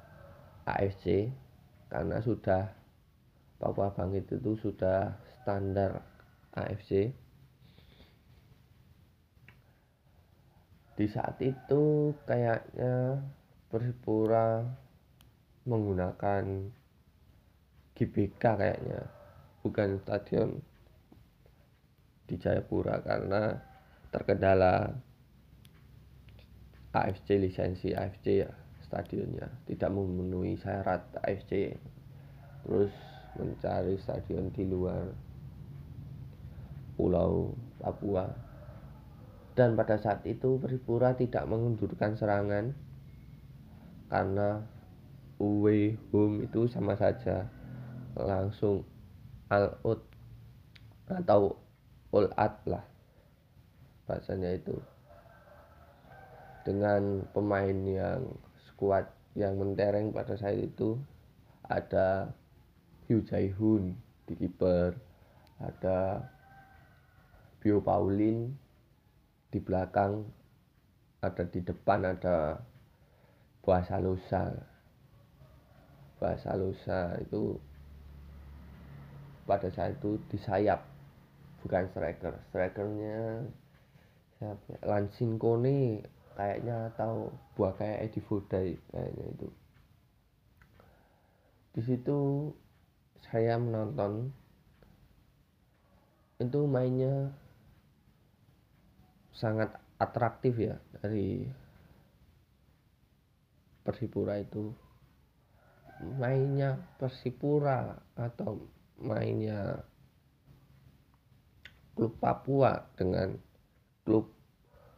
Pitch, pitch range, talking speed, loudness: 105 Hz, 95-120 Hz, 65 wpm, -33 LUFS